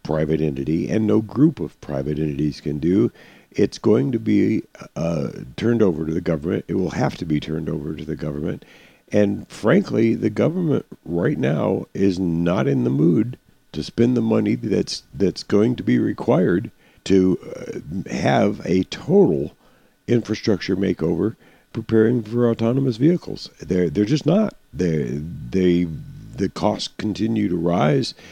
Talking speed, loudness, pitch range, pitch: 155 wpm, -21 LUFS, 80-110 Hz, 95 Hz